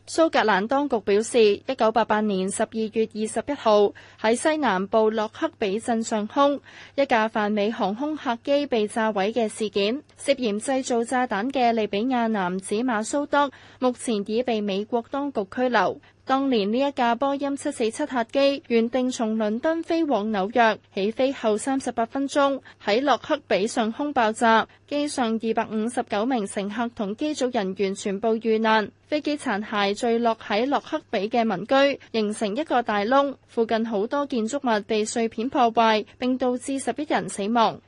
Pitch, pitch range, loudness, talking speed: 230 Hz, 215-265 Hz, -24 LUFS, 260 characters per minute